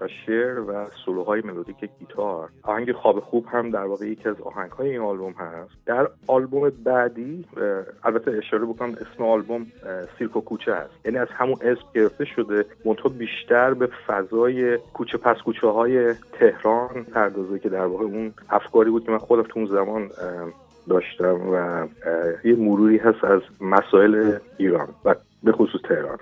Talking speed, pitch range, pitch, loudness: 160 wpm, 105-120 Hz, 110 Hz, -22 LUFS